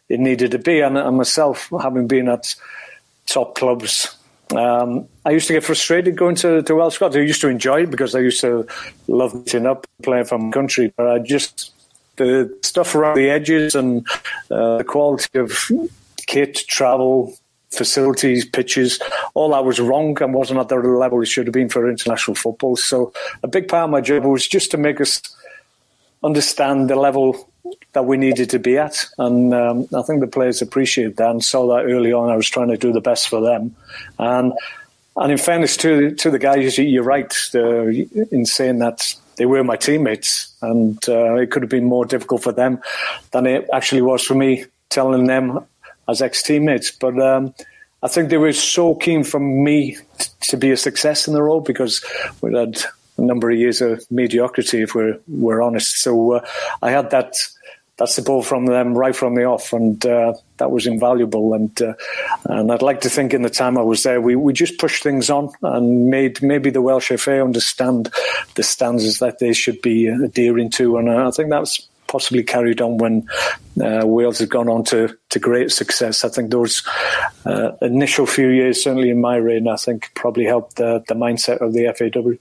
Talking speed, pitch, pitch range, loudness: 205 wpm, 125 Hz, 120-140 Hz, -17 LUFS